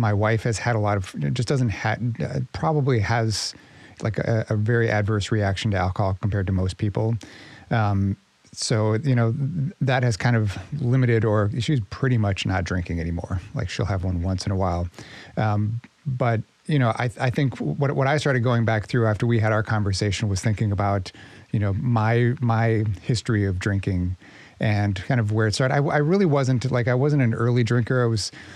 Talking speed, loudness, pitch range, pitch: 200 wpm, -23 LUFS, 100-125 Hz, 110 Hz